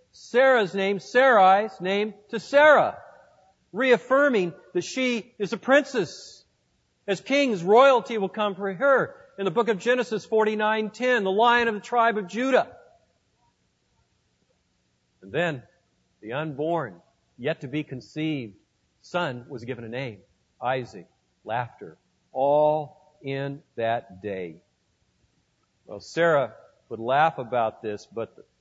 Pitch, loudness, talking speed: 195 Hz, -24 LUFS, 125 wpm